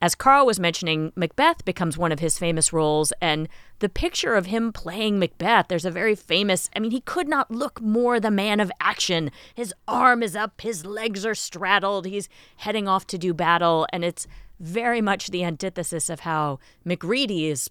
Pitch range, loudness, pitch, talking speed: 170-220 Hz, -23 LUFS, 190 Hz, 195 wpm